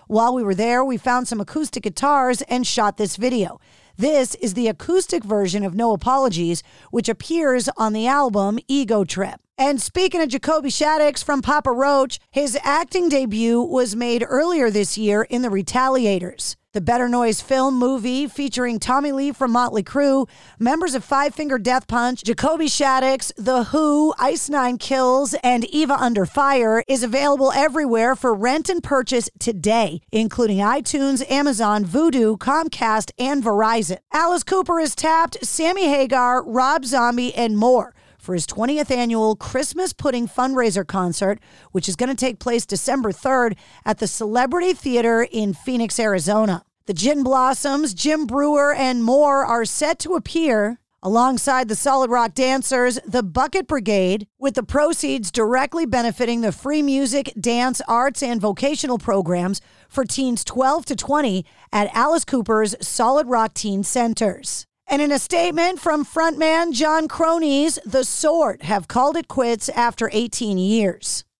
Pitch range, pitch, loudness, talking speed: 225-285 Hz, 255 Hz, -19 LUFS, 155 wpm